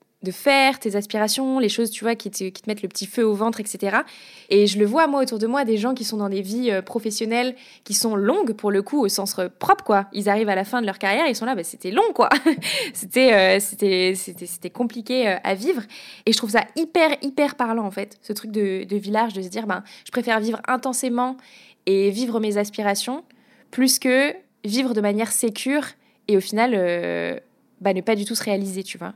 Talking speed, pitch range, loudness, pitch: 245 wpm, 200-255 Hz, -21 LUFS, 220 Hz